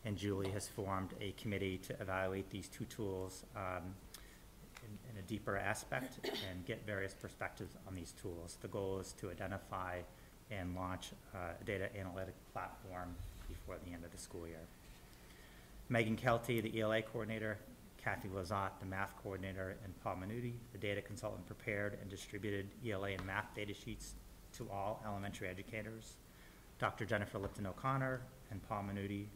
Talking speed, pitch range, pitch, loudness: 160 wpm, 95-105 Hz, 100 Hz, -44 LUFS